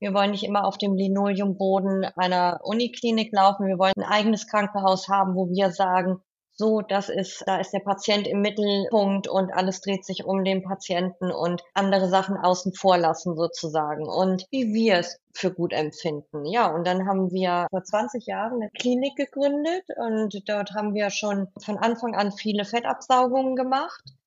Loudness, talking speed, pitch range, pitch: -24 LUFS, 175 wpm, 185-210 Hz, 195 Hz